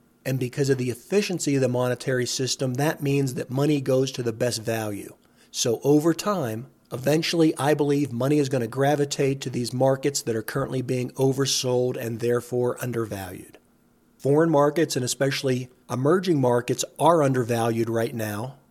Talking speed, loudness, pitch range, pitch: 160 wpm, -24 LUFS, 120-145 Hz, 130 Hz